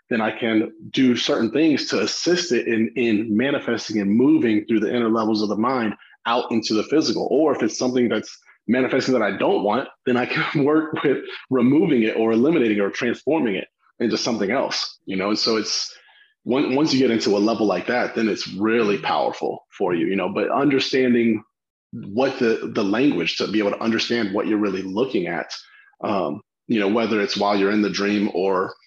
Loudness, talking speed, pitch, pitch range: -21 LUFS, 205 wpm, 115 Hz, 105-125 Hz